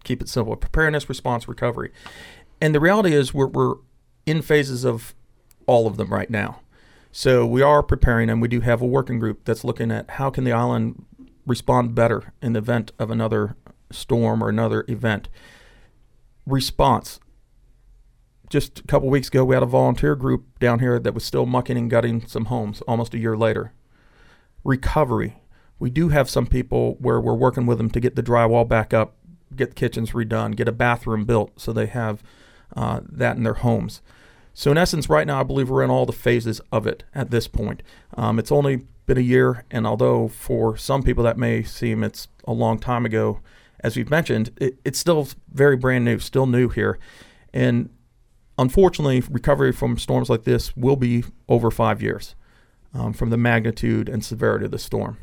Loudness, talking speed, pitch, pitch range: -21 LUFS, 190 wpm, 120 Hz, 115-130 Hz